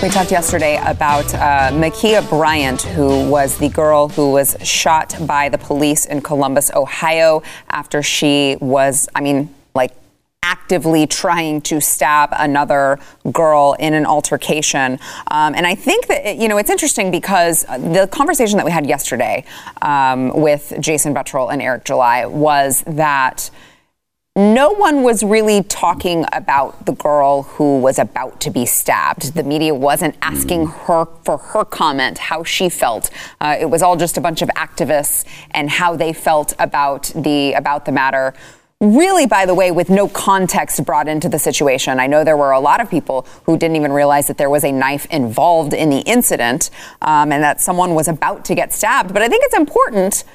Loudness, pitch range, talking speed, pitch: -14 LUFS, 145-175 Hz, 180 wpm, 155 Hz